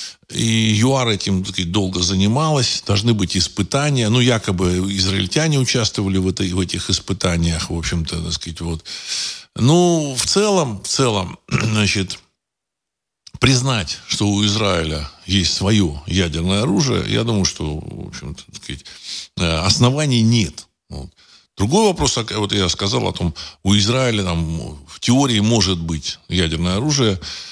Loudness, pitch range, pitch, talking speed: -18 LUFS, 90-120 Hz, 100 Hz, 135 wpm